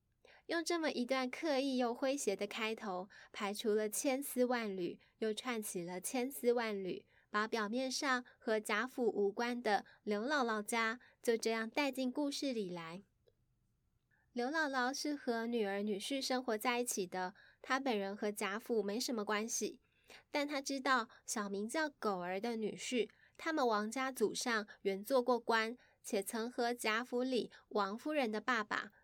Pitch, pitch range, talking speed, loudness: 230 Hz, 210-260 Hz, 230 characters per minute, -38 LUFS